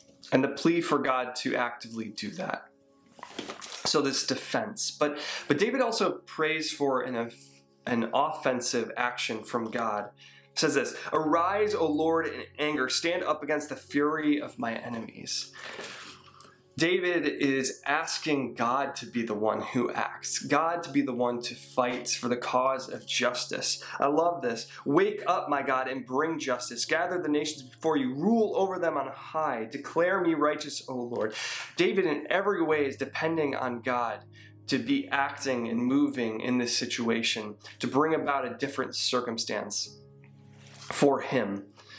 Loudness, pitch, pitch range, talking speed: -29 LUFS, 135 Hz, 120-155 Hz, 160 wpm